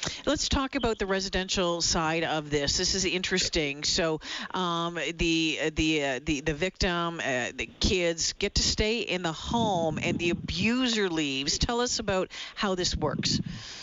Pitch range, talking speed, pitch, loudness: 160-195 Hz, 165 wpm, 175 Hz, -27 LUFS